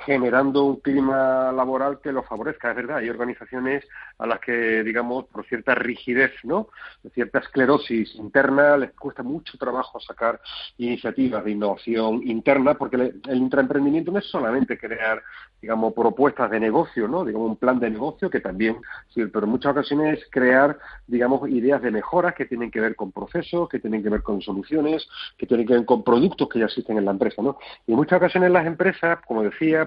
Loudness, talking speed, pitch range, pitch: -22 LUFS, 190 wpm, 115-145 Hz, 130 Hz